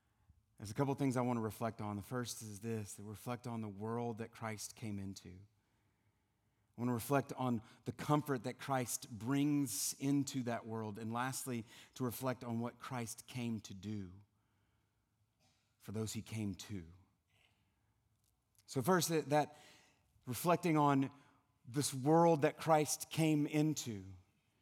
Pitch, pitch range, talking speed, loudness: 115 Hz, 105-135 Hz, 150 wpm, -38 LUFS